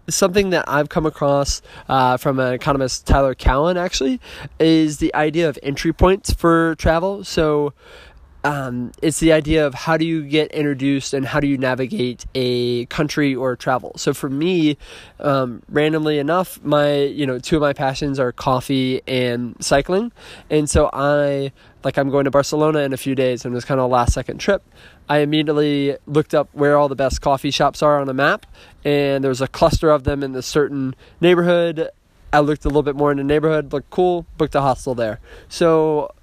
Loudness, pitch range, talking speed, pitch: -18 LUFS, 135-155 Hz, 195 wpm, 145 Hz